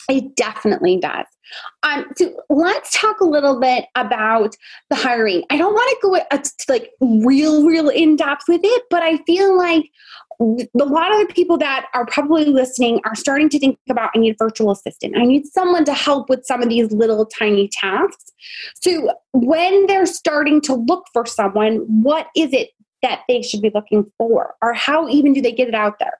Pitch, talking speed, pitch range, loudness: 280 Hz, 195 wpm, 235-340 Hz, -16 LUFS